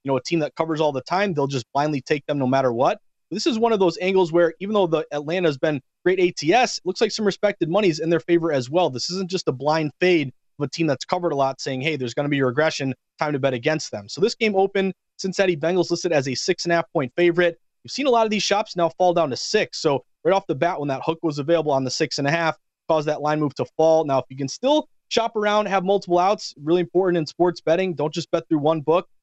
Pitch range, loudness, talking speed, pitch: 145-185 Hz, -22 LUFS, 290 wpm, 165 Hz